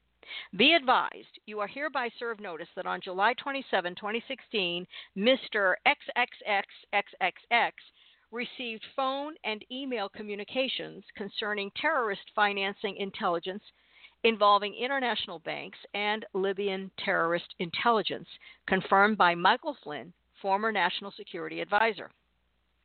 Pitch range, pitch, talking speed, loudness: 190-240 Hz, 205 Hz, 100 wpm, -29 LUFS